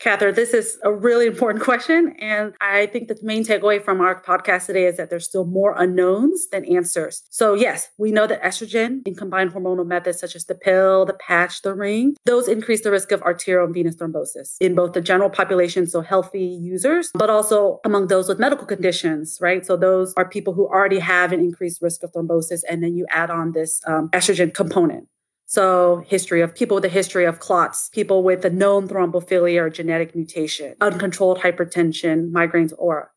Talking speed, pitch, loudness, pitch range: 200 wpm, 185 Hz, -19 LUFS, 175-205 Hz